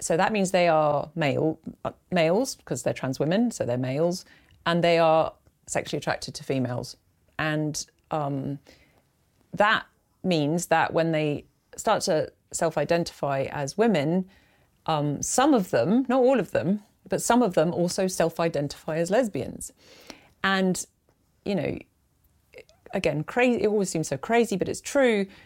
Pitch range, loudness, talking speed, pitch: 150-205 Hz, -25 LUFS, 145 wpm, 170 Hz